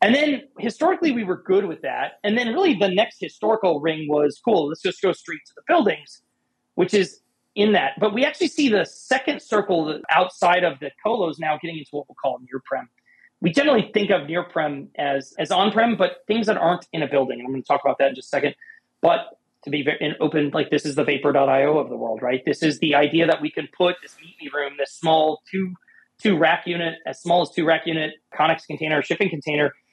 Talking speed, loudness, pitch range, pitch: 235 wpm, -22 LUFS, 150-205 Hz, 165 Hz